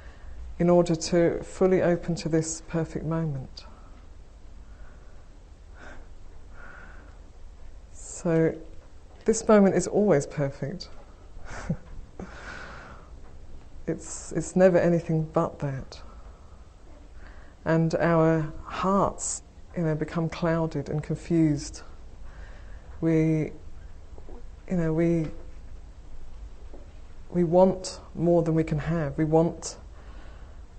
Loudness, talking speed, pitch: -26 LUFS, 85 wpm, 130 Hz